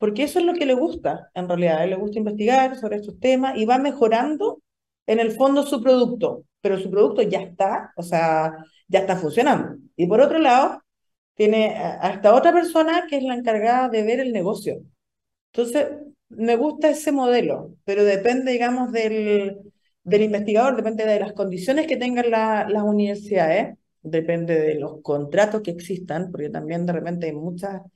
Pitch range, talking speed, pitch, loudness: 190-255 Hz, 180 wpm, 215 Hz, -21 LUFS